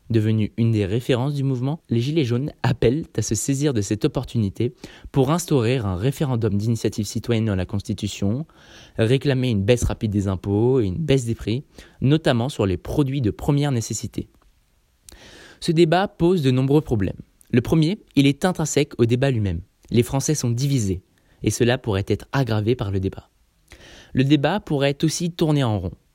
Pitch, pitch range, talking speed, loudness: 125 Hz, 105-145 Hz, 175 wpm, -22 LUFS